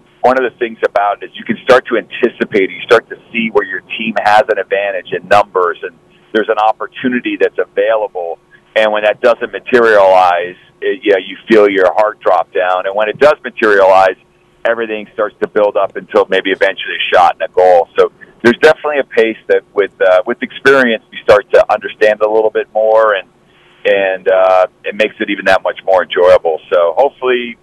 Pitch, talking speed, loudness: 120 Hz, 200 wpm, -12 LUFS